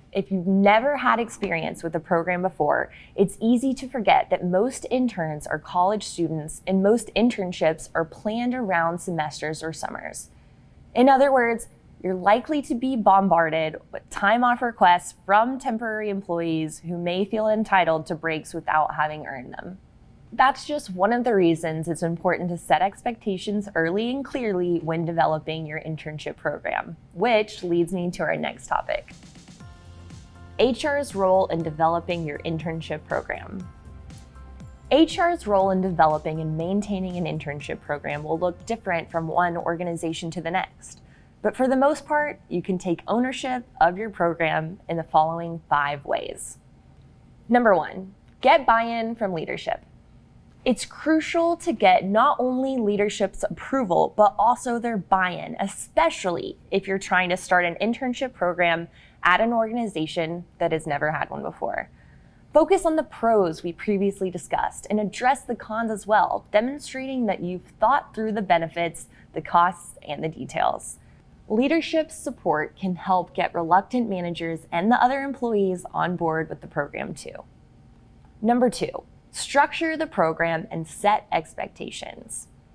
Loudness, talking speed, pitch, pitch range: -24 LUFS, 150 wpm, 185 Hz, 165-230 Hz